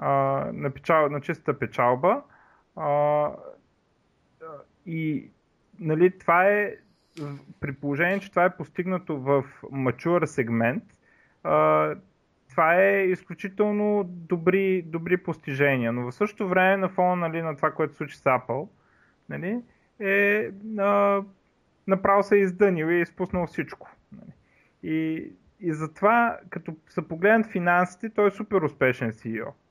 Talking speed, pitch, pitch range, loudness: 125 wpm, 175 Hz, 150-195 Hz, -25 LUFS